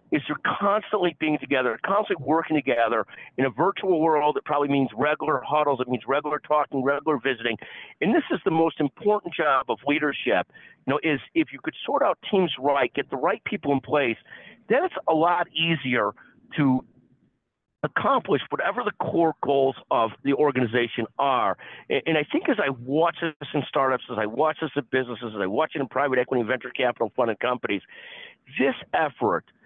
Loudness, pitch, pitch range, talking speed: -24 LUFS, 150 Hz, 135-165 Hz, 185 wpm